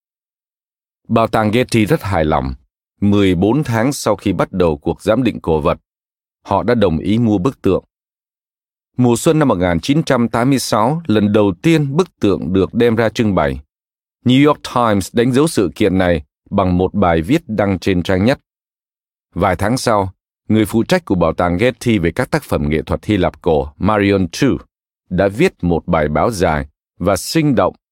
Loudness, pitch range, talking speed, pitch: -15 LUFS, 90-125 Hz, 180 wpm, 105 Hz